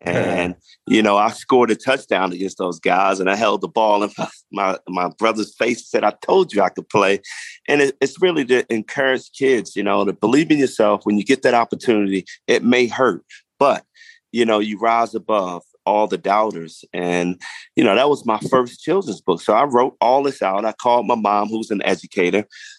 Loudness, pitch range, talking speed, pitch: -18 LUFS, 100-135 Hz, 210 wpm, 110 Hz